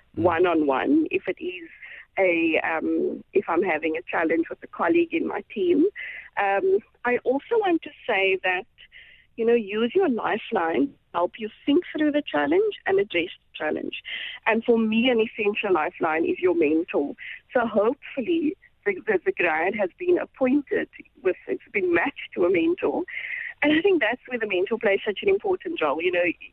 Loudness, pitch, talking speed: -24 LUFS, 285 Hz, 185 wpm